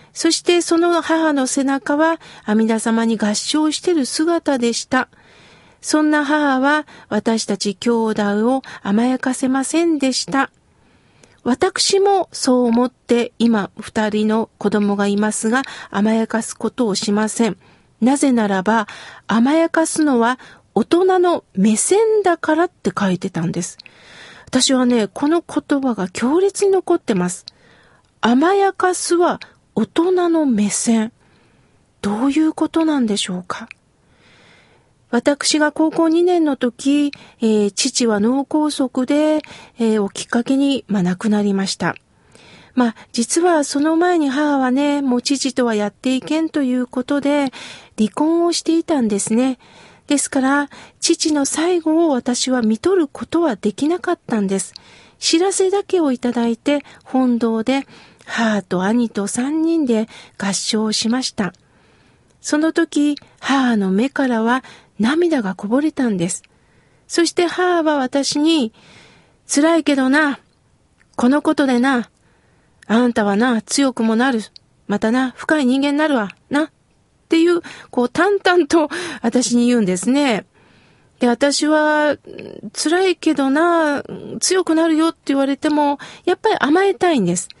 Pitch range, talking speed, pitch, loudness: 225-315 Hz, 255 characters per minute, 270 Hz, -17 LUFS